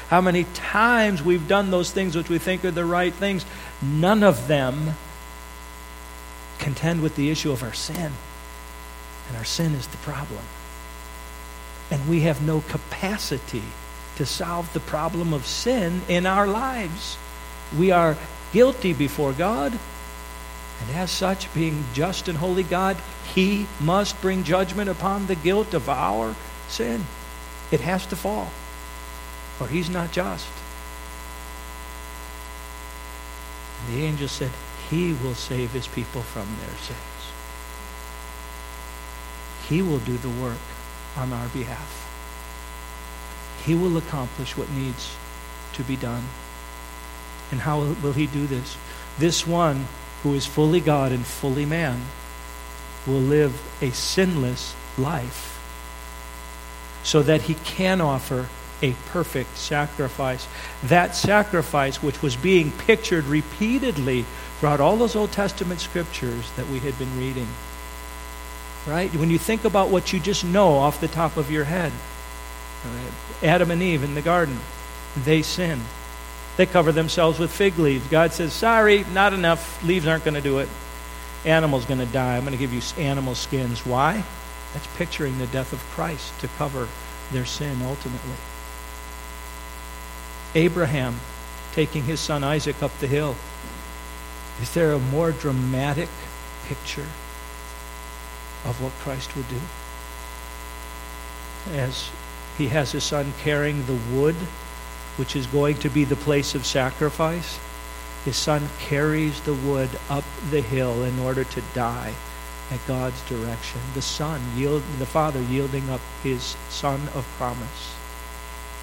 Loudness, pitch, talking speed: -24 LUFS, 130 Hz, 140 wpm